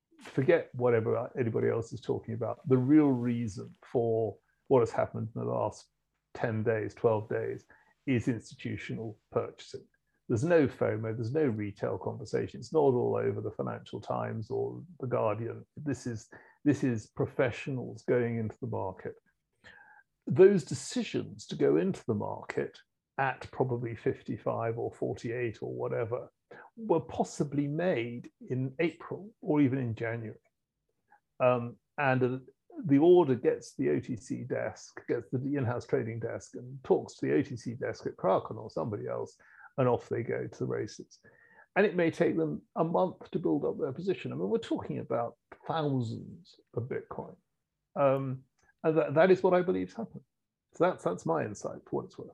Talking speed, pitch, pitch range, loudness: 170 wpm, 130 Hz, 115-160 Hz, -31 LUFS